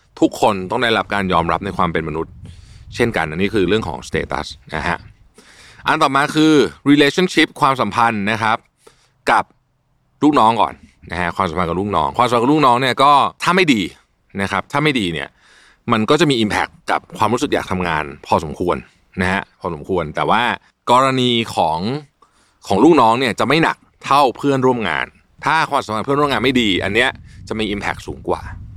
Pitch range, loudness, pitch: 95-135 Hz, -17 LUFS, 110 Hz